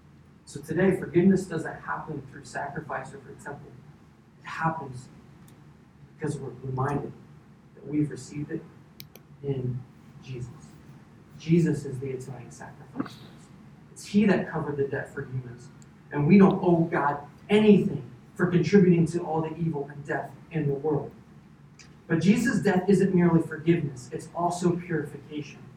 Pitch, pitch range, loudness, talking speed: 155 Hz, 140-175 Hz, -26 LUFS, 140 wpm